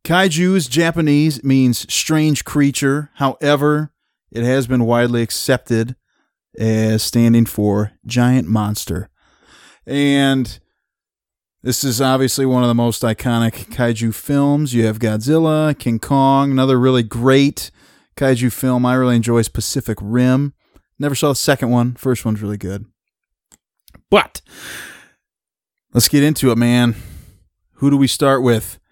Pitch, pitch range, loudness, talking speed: 125 Hz, 115-140 Hz, -16 LUFS, 130 wpm